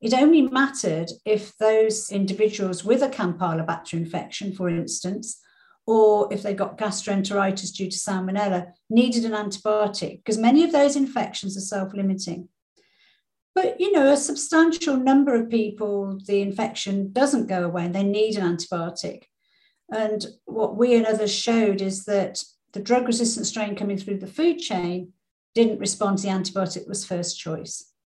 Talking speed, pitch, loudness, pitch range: 155 wpm, 205 Hz, -23 LUFS, 190-235 Hz